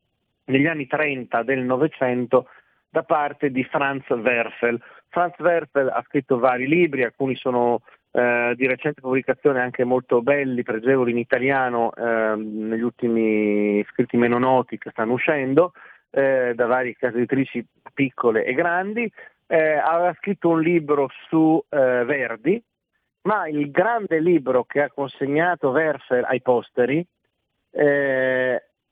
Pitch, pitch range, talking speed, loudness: 130 Hz, 120-150 Hz, 135 wpm, -21 LUFS